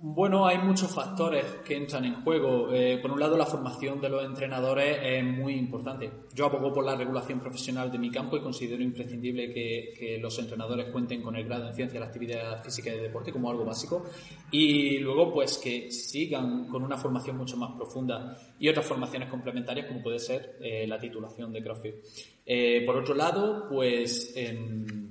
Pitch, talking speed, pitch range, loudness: 125 Hz, 195 wpm, 120-140 Hz, -30 LUFS